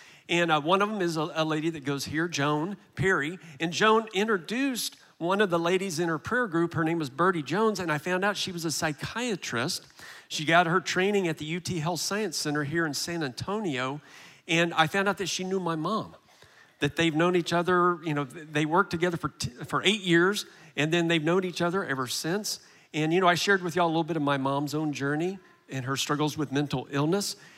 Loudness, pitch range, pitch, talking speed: -27 LUFS, 150-185 Hz, 170 Hz, 230 wpm